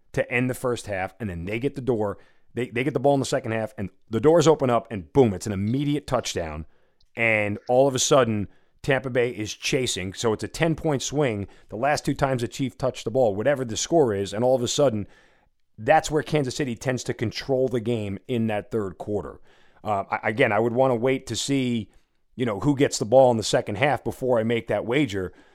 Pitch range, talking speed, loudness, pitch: 105-135 Hz, 235 wpm, -24 LUFS, 120 Hz